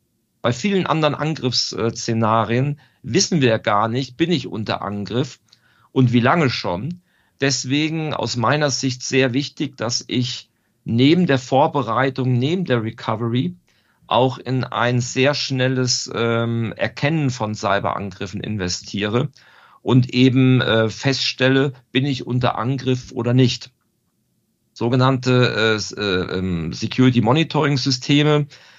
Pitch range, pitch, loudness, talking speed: 115-135 Hz, 125 Hz, -19 LUFS, 110 wpm